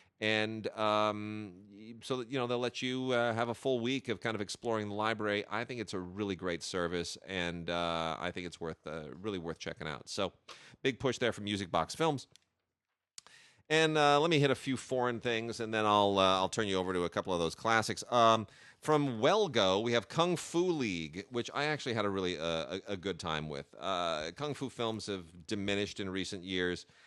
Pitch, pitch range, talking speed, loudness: 110 Hz, 95-125 Hz, 215 wpm, -33 LUFS